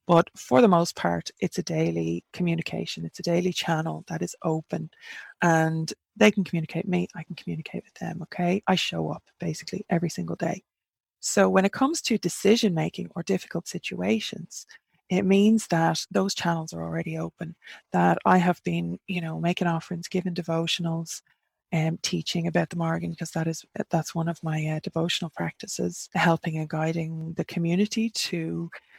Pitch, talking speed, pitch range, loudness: 170 Hz, 175 wpm, 160-185 Hz, -26 LUFS